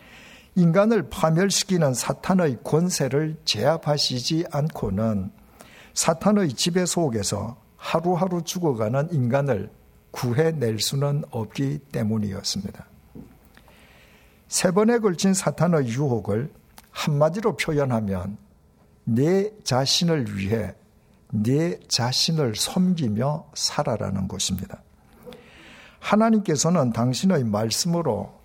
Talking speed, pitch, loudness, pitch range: 230 characters per minute, 145 Hz, -23 LUFS, 115-170 Hz